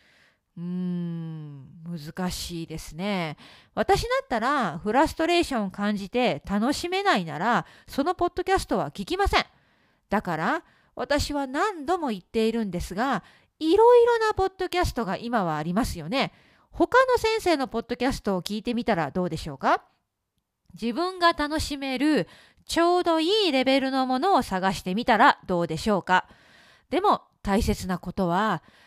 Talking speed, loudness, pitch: 320 characters per minute, -25 LUFS, 240 Hz